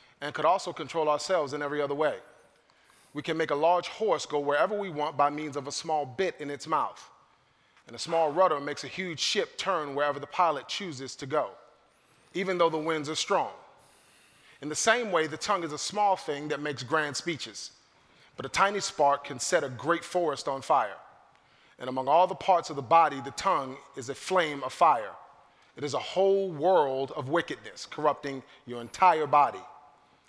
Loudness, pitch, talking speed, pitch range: -28 LUFS, 150 Hz, 200 wpm, 145-175 Hz